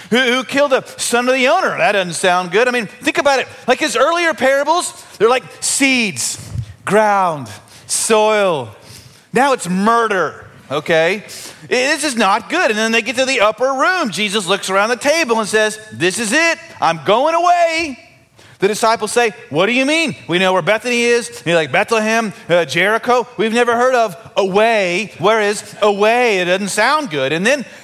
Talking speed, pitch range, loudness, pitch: 185 wpm, 185-260 Hz, -15 LUFS, 220 Hz